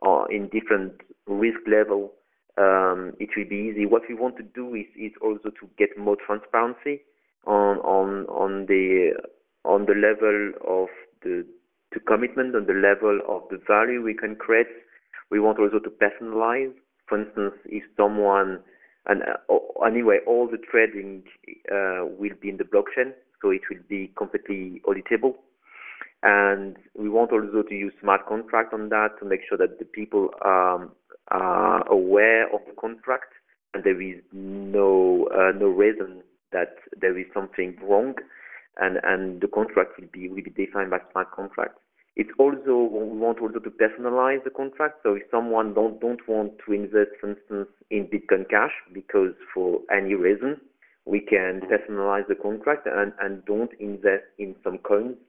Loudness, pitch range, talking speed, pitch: -24 LUFS, 100-125 Hz, 165 wpm, 105 Hz